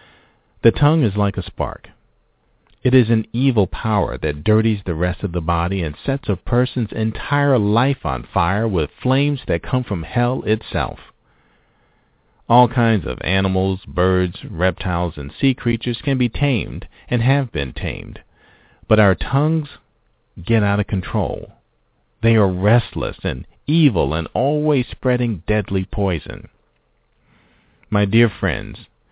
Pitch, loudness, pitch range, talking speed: 105 Hz, -19 LUFS, 90-125 Hz, 140 wpm